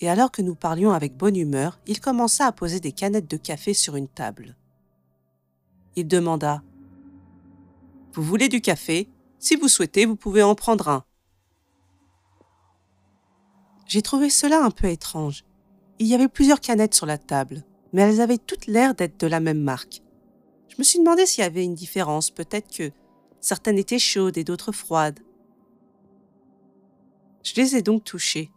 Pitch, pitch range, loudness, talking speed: 175 Hz, 135-215 Hz, -21 LUFS, 165 wpm